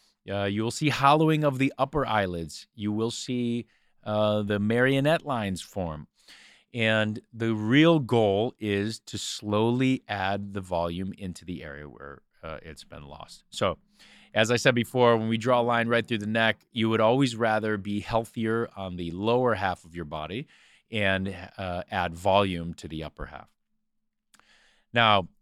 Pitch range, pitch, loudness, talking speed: 95-120 Hz, 110 Hz, -26 LUFS, 170 wpm